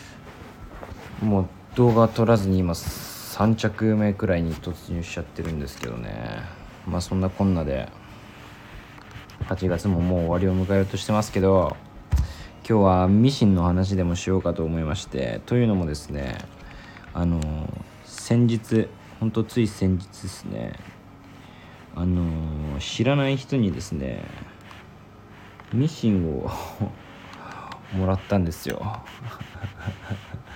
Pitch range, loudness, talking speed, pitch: 90-110 Hz, -24 LUFS, 240 characters per minute, 95 Hz